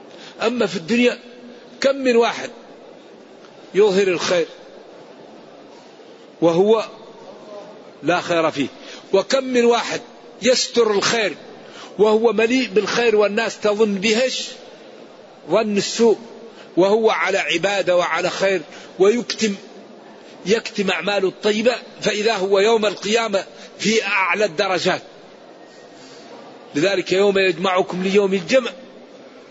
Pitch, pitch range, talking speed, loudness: 215 Hz, 195-235 Hz, 95 wpm, -18 LUFS